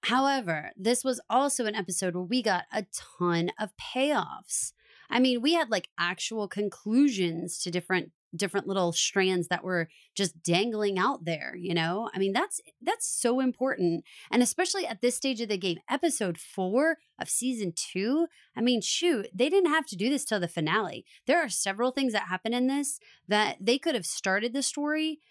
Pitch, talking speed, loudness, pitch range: 220 Hz, 185 wpm, -28 LUFS, 185-265 Hz